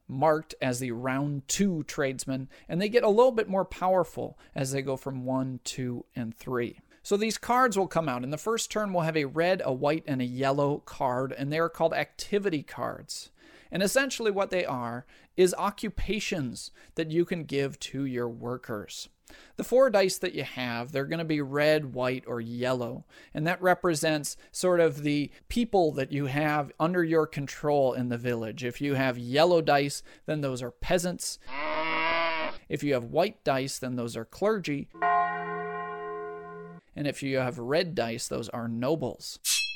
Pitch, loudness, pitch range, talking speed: 145 Hz, -29 LUFS, 125-175 Hz, 180 wpm